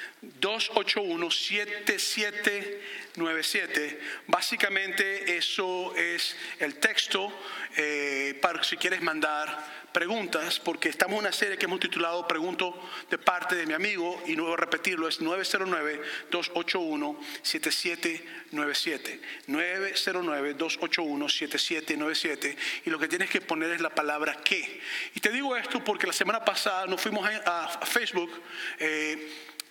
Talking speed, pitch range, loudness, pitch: 120 wpm, 160-210 Hz, -28 LUFS, 180 Hz